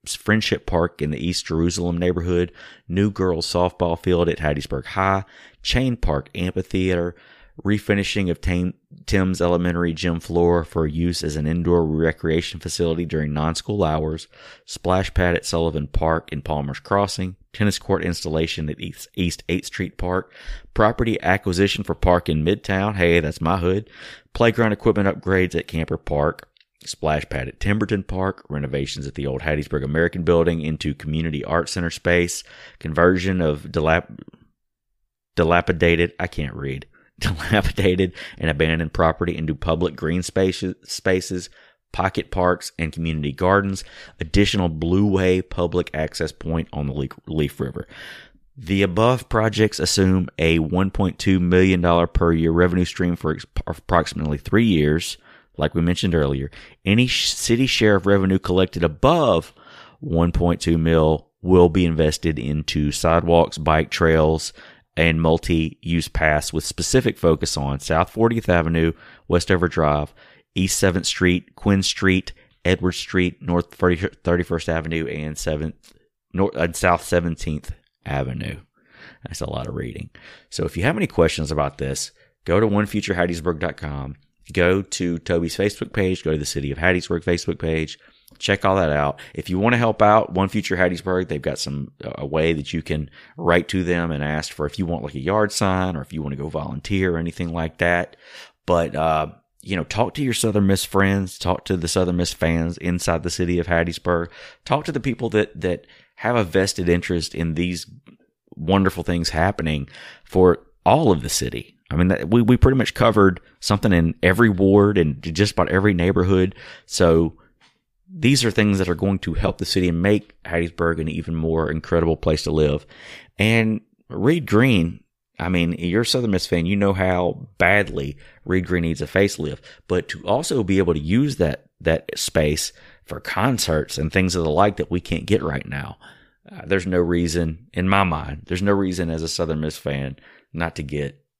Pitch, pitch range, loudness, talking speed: 85 Hz, 80-95 Hz, -21 LUFS, 165 wpm